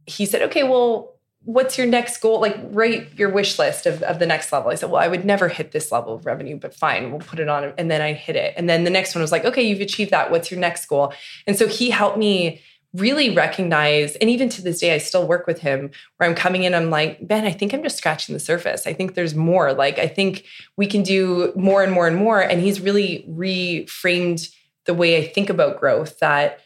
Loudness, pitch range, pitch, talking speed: -19 LUFS, 160-205 Hz, 180 Hz, 250 wpm